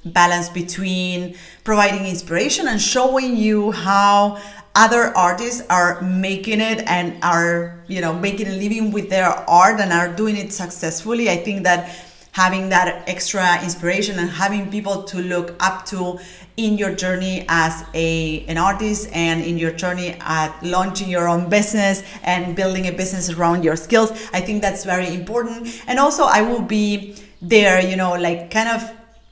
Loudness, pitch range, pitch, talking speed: -18 LUFS, 175-210 Hz, 185 Hz, 165 wpm